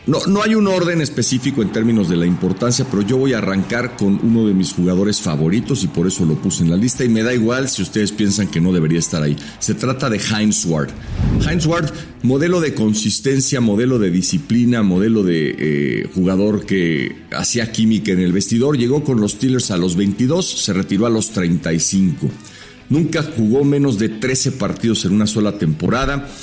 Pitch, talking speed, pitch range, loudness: 110 Hz, 200 wpm, 95-130 Hz, -16 LUFS